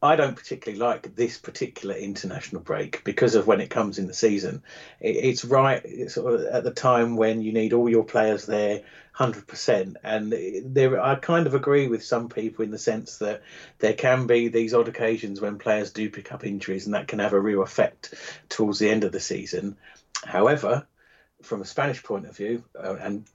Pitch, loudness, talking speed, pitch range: 110 Hz, -25 LUFS, 195 wpm, 105-125 Hz